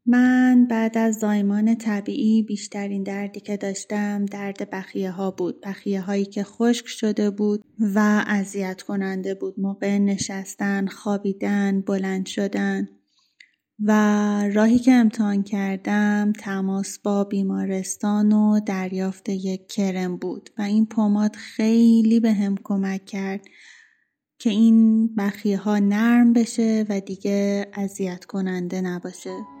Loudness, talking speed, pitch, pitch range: -22 LUFS, 120 wpm, 205 Hz, 195-215 Hz